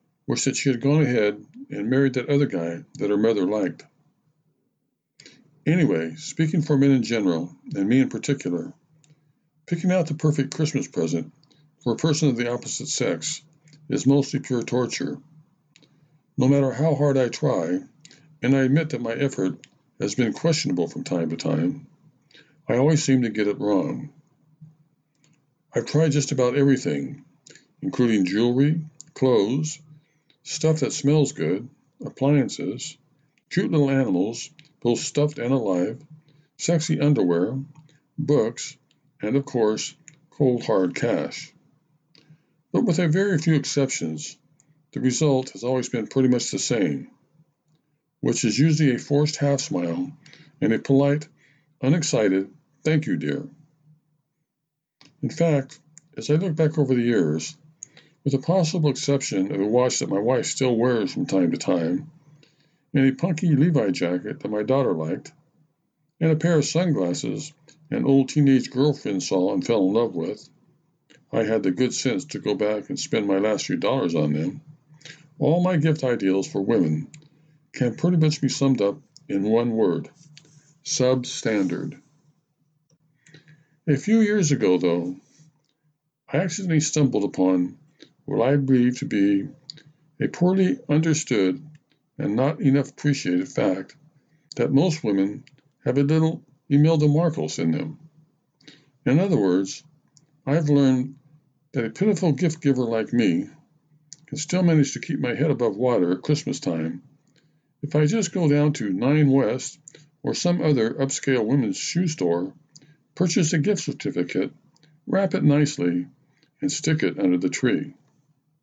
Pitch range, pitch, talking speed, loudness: 135-155 Hz, 145 Hz, 145 wpm, -23 LUFS